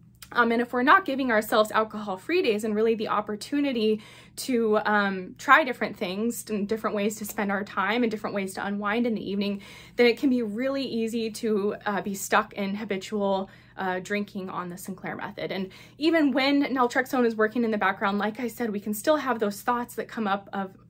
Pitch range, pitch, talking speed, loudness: 200-240 Hz, 215 Hz, 210 wpm, -26 LUFS